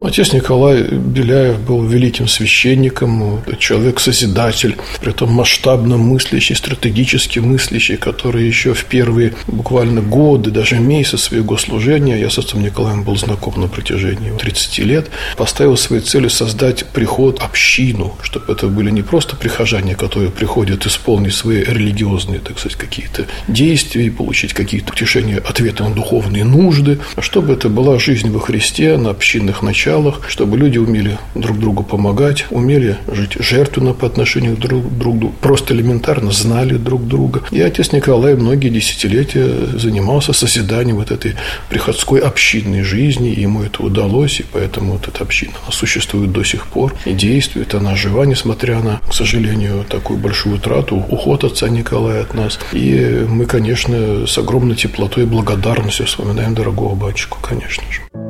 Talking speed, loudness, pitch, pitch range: 150 wpm, -13 LUFS, 115 Hz, 105-125 Hz